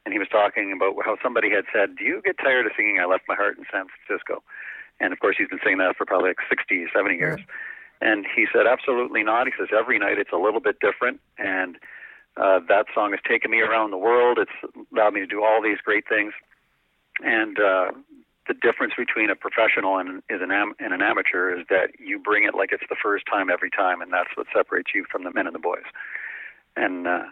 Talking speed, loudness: 230 wpm, -22 LUFS